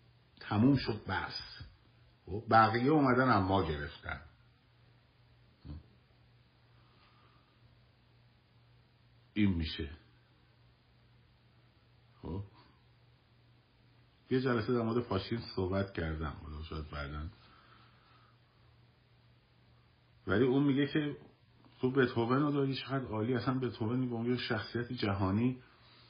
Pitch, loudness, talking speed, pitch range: 120 Hz, -33 LUFS, 80 wpm, 110-125 Hz